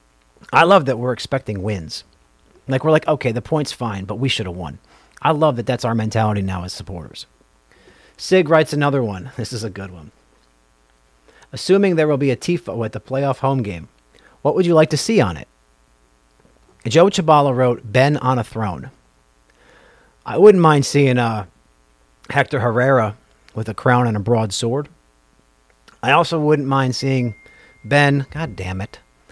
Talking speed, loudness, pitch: 175 wpm, -18 LUFS, 115 Hz